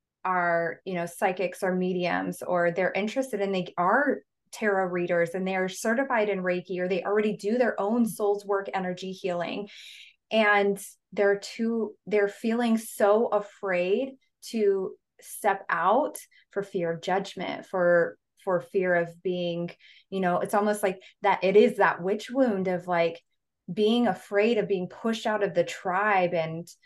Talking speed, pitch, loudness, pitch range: 160 wpm, 195 Hz, -27 LUFS, 180-210 Hz